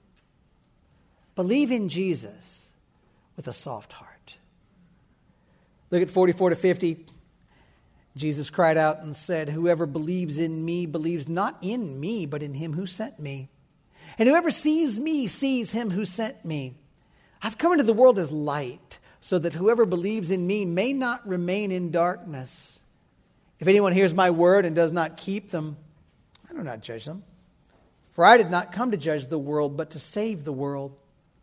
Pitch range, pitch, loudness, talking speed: 155-205 Hz, 175 Hz, -24 LUFS, 165 wpm